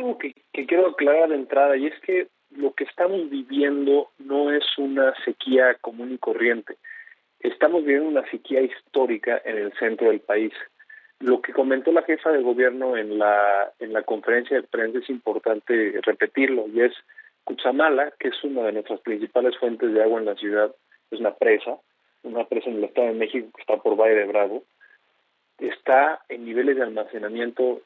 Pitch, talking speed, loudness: 140 Hz, 175 wpm, -23 LUFS